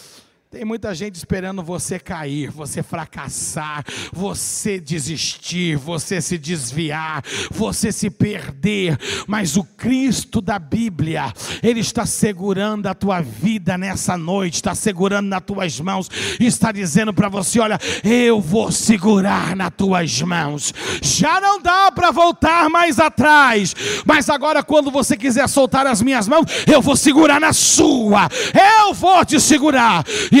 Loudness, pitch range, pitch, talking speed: -16 LUFS, 175-265 Hz, 205 Hz, 140 wpm